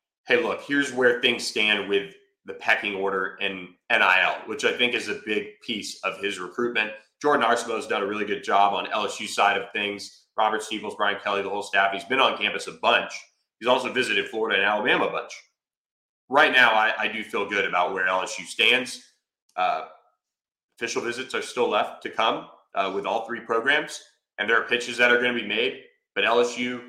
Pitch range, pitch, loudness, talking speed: 100-125 Hz, 110 Hz, -23 LUFS, 205 wpm